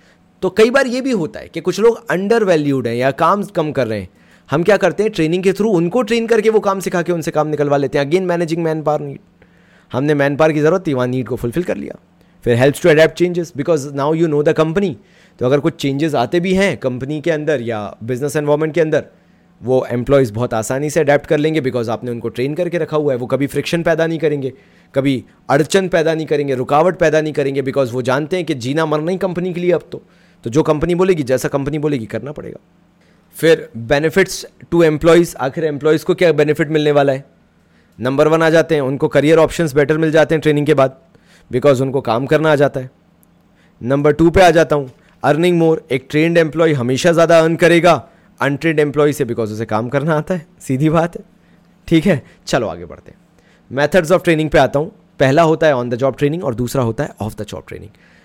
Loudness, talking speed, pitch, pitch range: -15 LUFS, 230 wpm, 155 Hz, 140-170 Hz